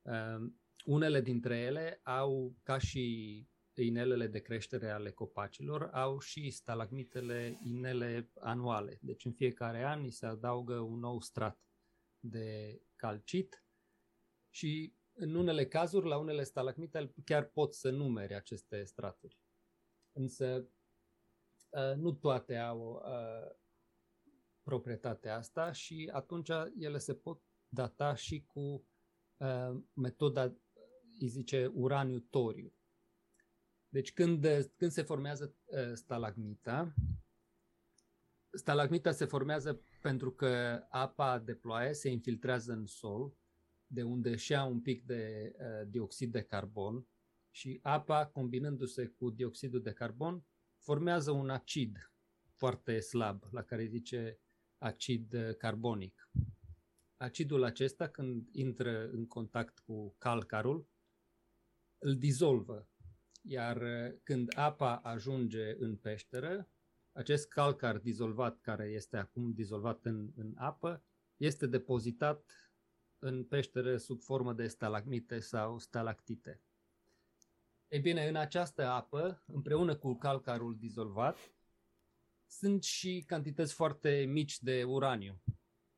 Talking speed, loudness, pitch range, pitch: 110 wpm, -38 LUFS, 110-140 Hz, 120 Hz